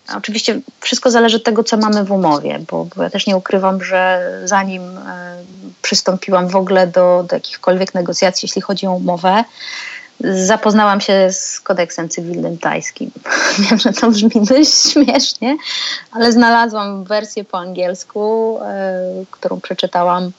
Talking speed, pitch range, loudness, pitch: 145 wpm, 185-230 Hz, -14 LUFS, 200 Hz